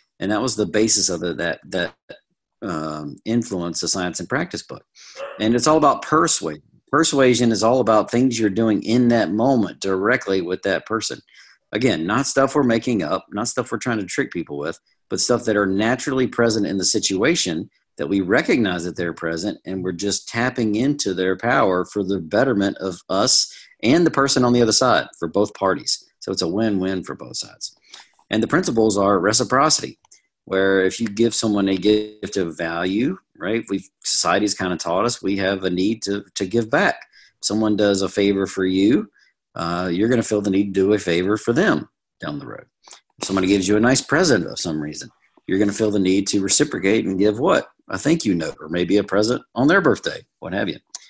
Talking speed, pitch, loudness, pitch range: 210 wpm, 105 Hz, -20 LUFS, 95-115 Hz